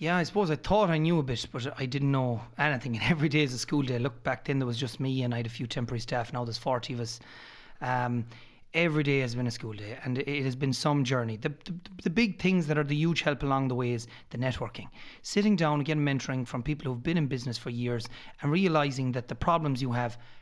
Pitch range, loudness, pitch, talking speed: 120-150 Hz, -30 LUFS, 130 Hz, 265 wpm